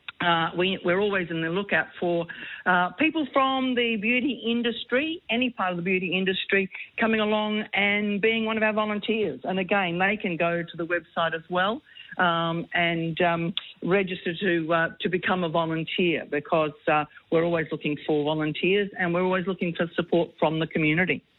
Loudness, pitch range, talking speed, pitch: -25 LUFS, 170-210 Hz, 180 wpm, 180 Hz